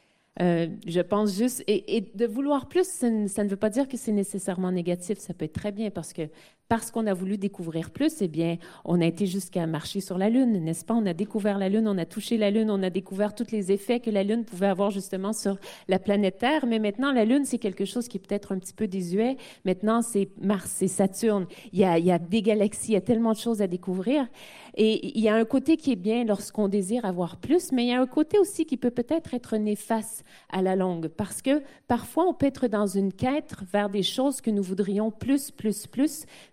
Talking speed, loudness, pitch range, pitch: 250 wpm, -26 LUFS, 195-240 Hz, 210 Hz